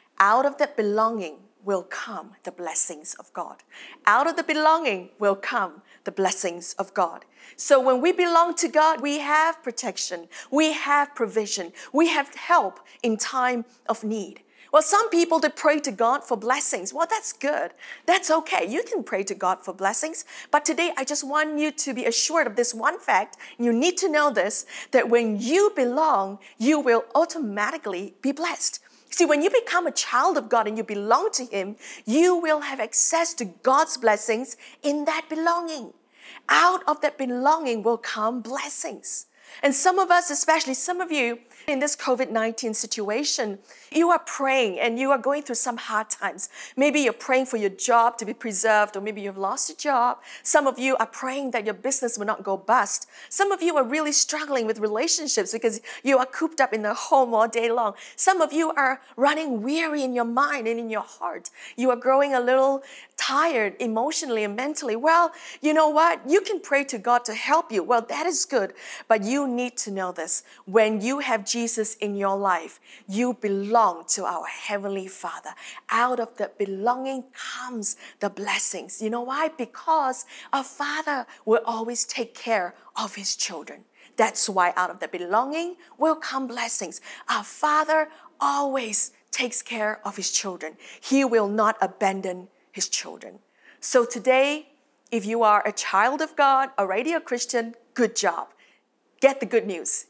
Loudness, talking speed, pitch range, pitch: -23 LUFS, 180 wpm, 220-300 Hz, 250 Hz